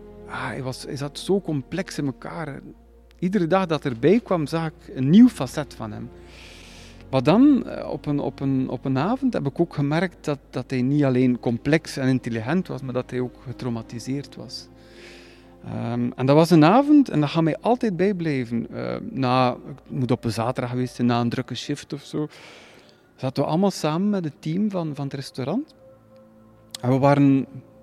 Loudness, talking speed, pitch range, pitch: -23 LUFS, 190 wpm, 125-160 Hz, 135 Hz